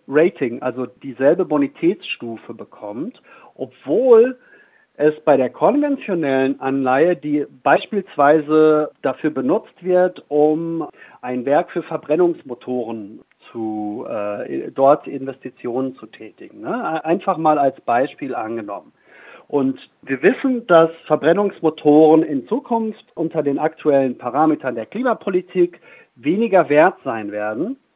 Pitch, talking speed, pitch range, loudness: 155 Hz, 105 wpm, 135-180 Hz, -18 LUFS